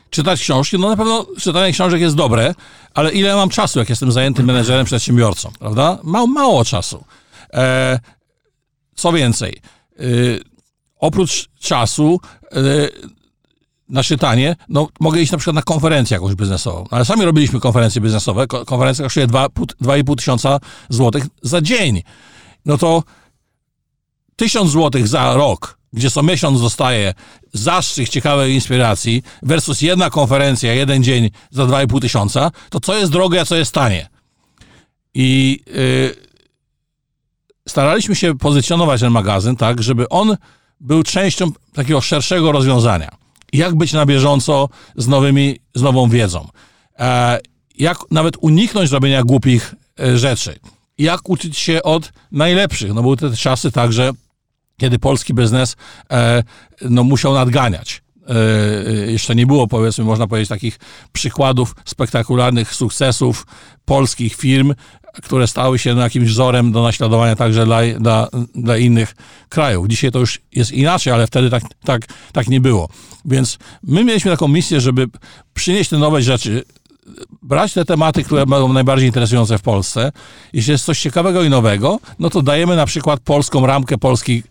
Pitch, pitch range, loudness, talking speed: 130 Hz, 120-155 Hz, -15 LUFS, 140 wpm